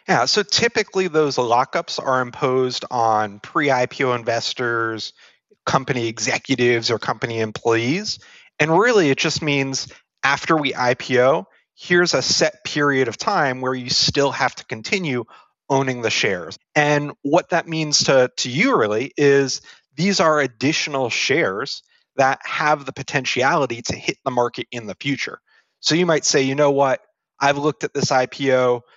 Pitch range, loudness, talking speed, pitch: 125-155 Hz, -19 LUFS, 155 wpm, 135 Hz